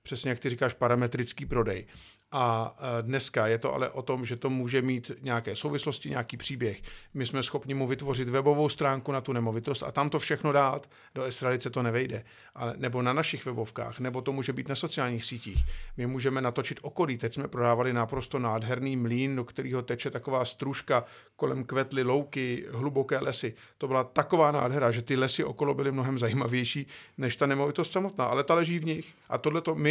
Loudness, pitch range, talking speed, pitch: -30 LUFS, 120-140 Hz, 190 wpm, 130 Hz